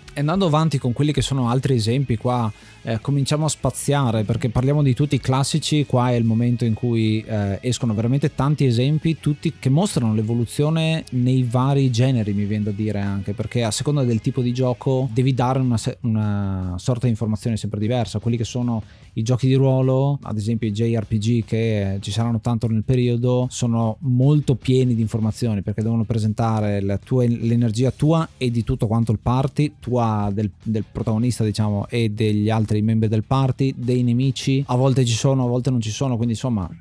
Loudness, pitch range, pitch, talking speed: -21 LUFS, 110-130 Hz, 120 Hz, 190 wpm